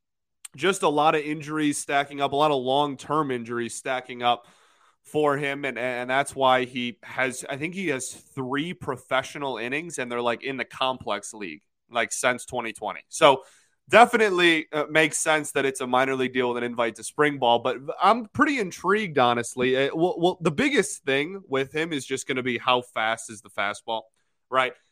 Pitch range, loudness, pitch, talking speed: 125-150 Hz, -24 LUFS, 135 Hz, 190 wpm